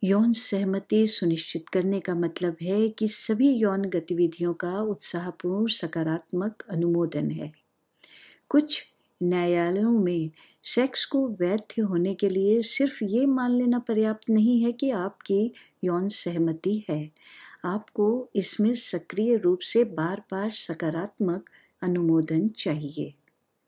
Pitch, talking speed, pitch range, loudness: 195 Hz, 120 wpm, 175-220 Hz, -26 LUFS